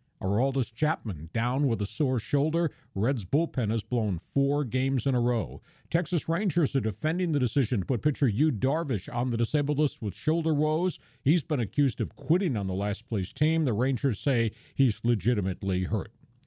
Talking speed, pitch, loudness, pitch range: 180 wpm, 135 Hz, -28 LUFS, 115-150 Hz